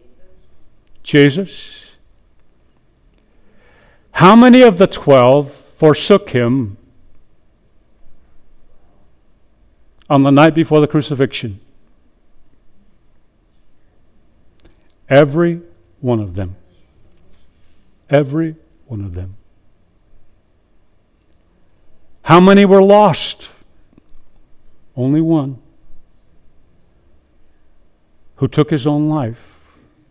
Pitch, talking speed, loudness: 105 Hz, 65 wpm, -12 LUFS